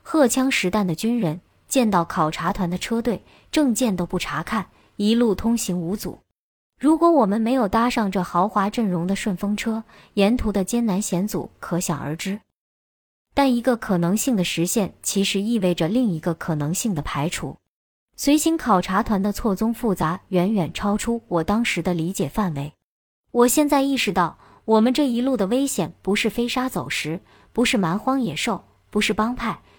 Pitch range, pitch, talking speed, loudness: 180-240 Hz, 210 Hz, 260 characters per minute, -22 LUFS